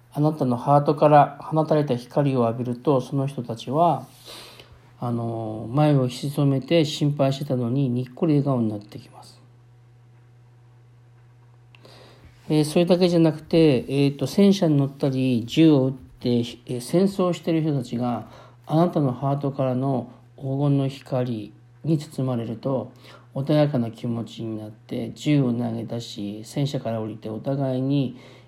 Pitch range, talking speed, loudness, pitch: 120-145 Hz, 290 characters per minute, -23 LUFS, 130 Hz